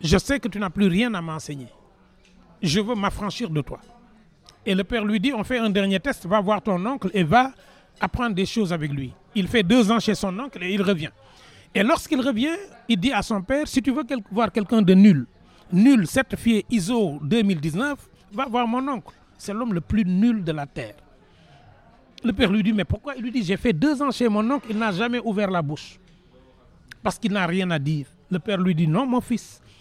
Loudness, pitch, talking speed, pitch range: -22 LUFS, 210 Hz, 225 wpm, 185-240 Hz